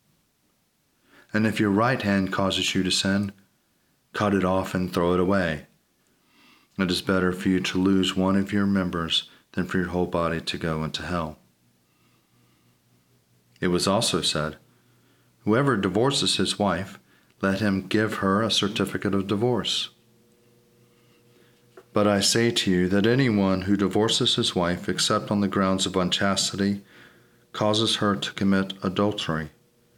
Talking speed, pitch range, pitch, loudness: 150 wpm, 90-105 Hz, 95 Hz, -24 LUFS